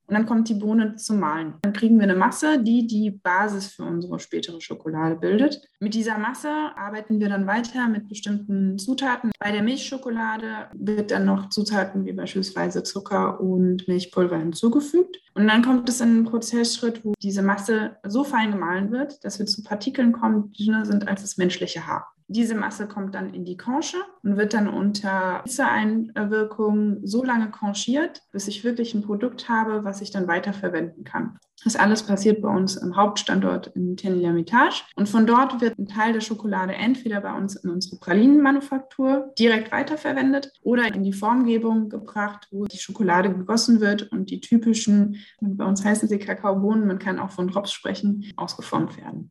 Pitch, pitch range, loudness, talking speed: 210 Hz, 195-235 Hz, -23 LUFS, 180 wpm